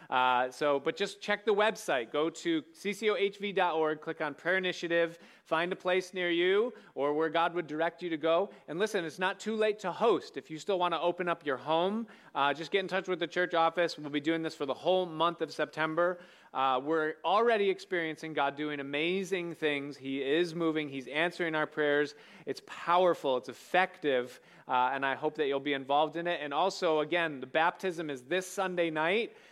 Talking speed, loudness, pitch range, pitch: 205 wpm, -31 LUFS, 150-185 Hz, 165 Hz